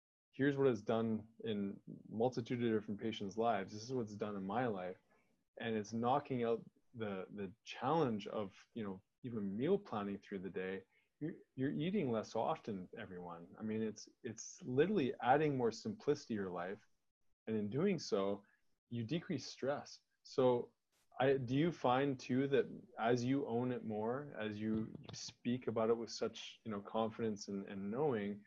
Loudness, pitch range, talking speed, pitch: -40 LUFS, 105-135 Hz, 175 wpm, 115 Hz